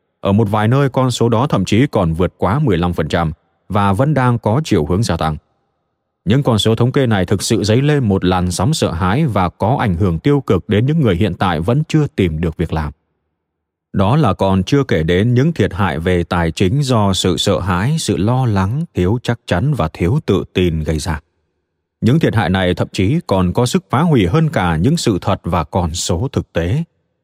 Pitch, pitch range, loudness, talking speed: 100 Hz, 90-125 Hz, -15 LUFS, 225 wpm